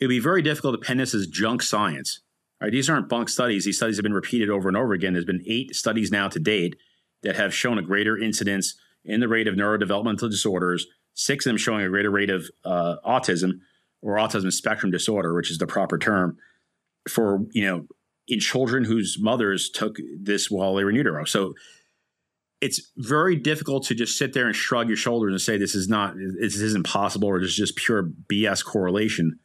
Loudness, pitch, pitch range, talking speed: -24 LUFS, 105 Hz, 95-115 Hz, 210 wpm